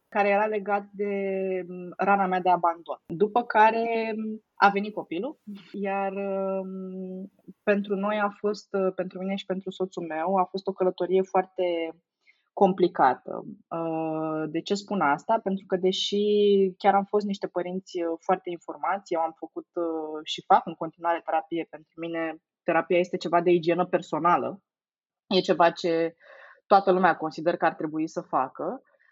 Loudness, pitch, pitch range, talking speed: -26 LUFS, 185 Hz, 170-200 Hz, 145 wpm